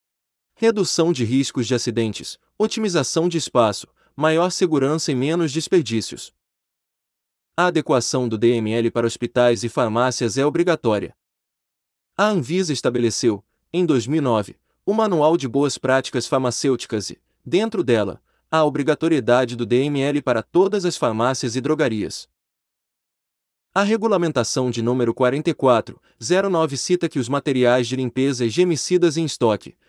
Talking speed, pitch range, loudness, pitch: 125 wpm, 120-165 Hz, -20 LUFS, 135 Hz